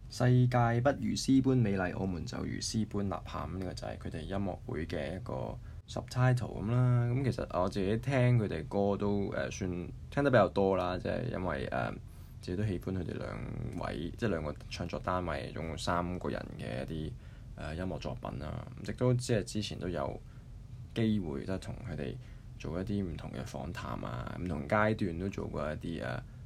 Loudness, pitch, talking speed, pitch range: -34 LUFS, 105 Hz, 305 characters per minute, 90-120 Hz